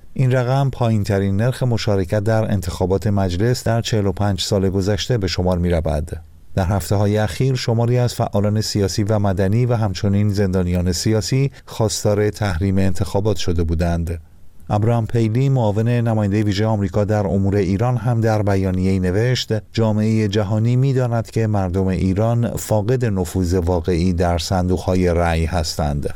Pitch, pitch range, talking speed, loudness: 105 Hz, 95-115 Hz, 145 wpm, -19 LUFS